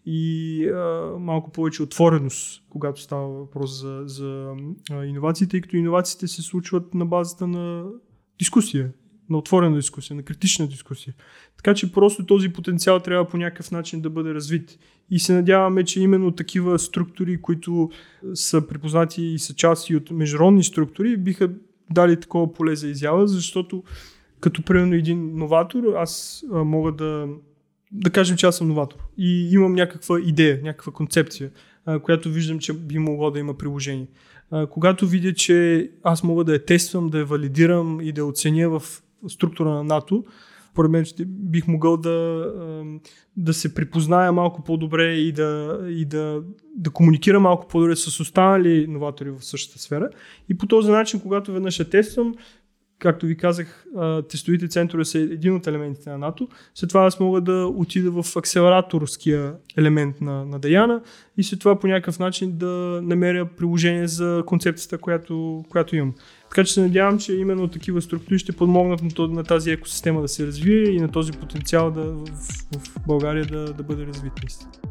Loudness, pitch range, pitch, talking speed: -21 LUFS, 155-180 Hz, 165 Hz, 165 wpm